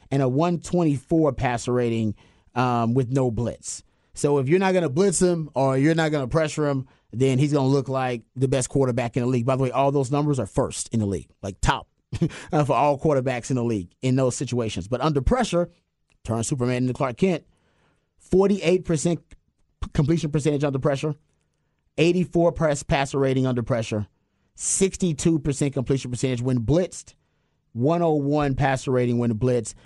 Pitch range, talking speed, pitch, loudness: 125-155 Hz, 180 wpm, 135 Hz, -23 LUFS